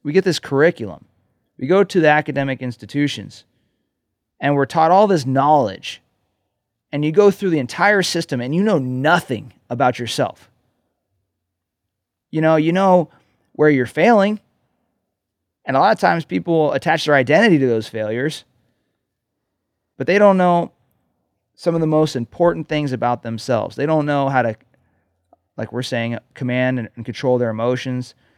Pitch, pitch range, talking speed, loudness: 135 Hz, 115-160 Hz, 155 wpm, -17 LUFS